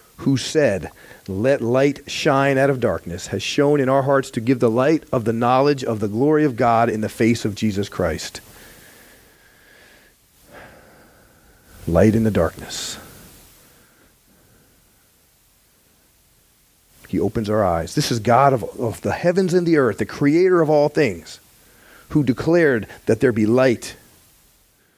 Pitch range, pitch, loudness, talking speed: 110-140 Hz, 130 Hz, -19 LUFS, 145 wpm